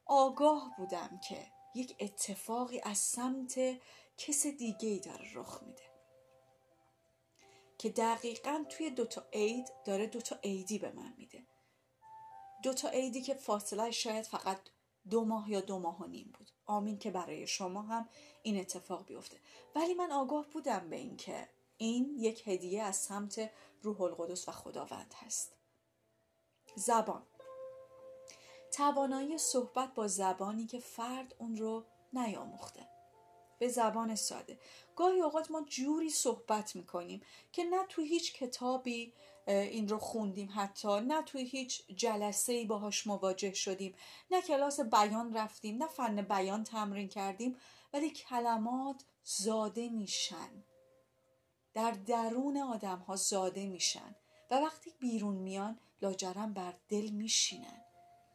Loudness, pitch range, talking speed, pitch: -37 LUFS, 195-260 Hz, 130 wpm, 220 Hz